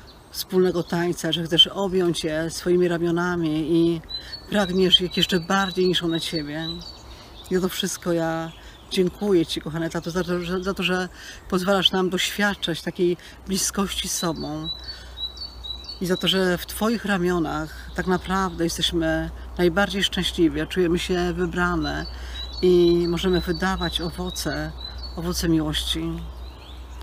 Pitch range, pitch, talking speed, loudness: 160-185 Hz, 175 Hz, 130 wpm, -23 LUFS